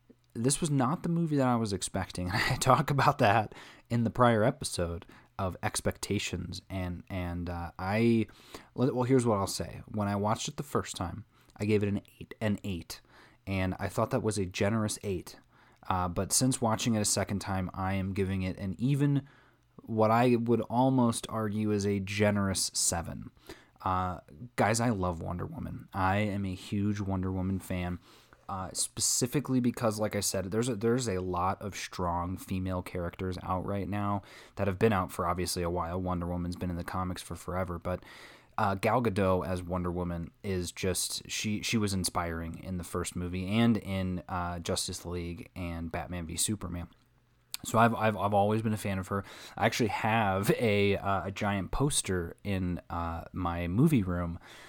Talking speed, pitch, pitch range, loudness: 185 wpm, 100 Hz, 90-115 Hz, -31 LUFS